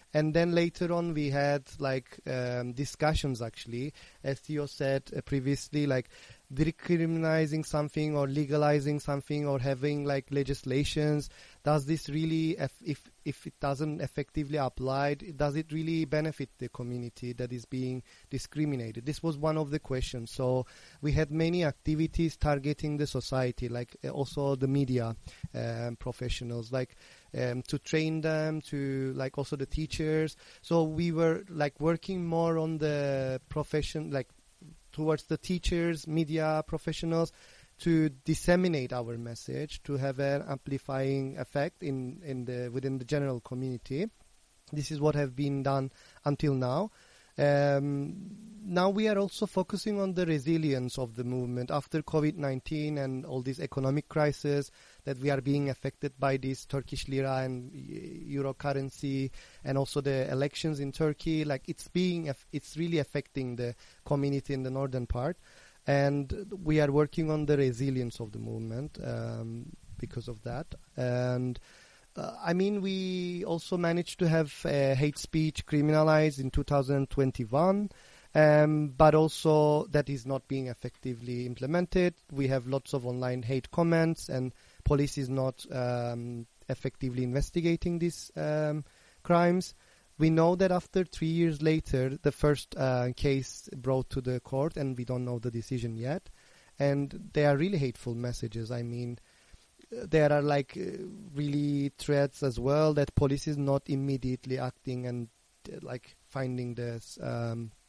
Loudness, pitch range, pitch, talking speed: -31 LUFS, 130-155 Hz, 140 Hz, 150 wpm